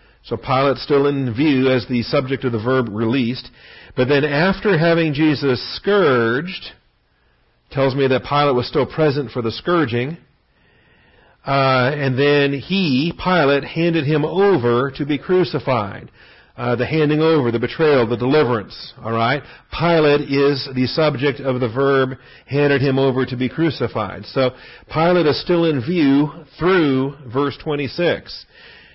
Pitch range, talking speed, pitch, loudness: 125-155 Hz, 145 wpm, 140 Hz, -18 LUFS